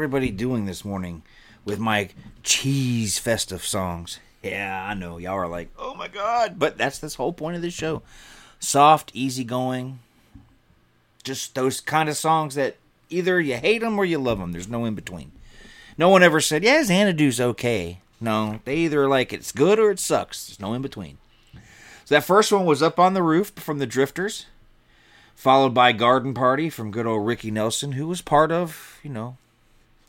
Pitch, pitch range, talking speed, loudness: 130 Hz, 110-155 Hz, 185 wpm, -22 LUFS